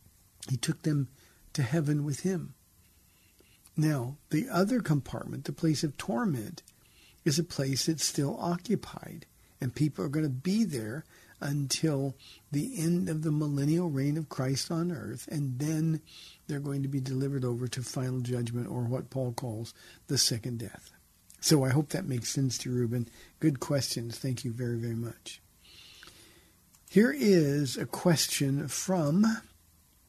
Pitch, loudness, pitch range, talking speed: 140 Hz, -31 LUFS, 125-160 Hz, 155 wpm